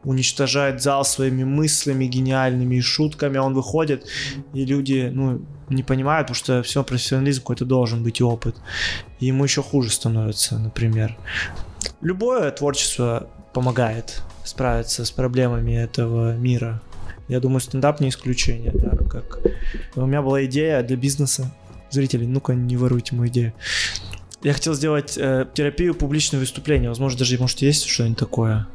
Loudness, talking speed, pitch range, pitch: -21 LUFS, 140 wpm, 120-140 Hz, 130 Hz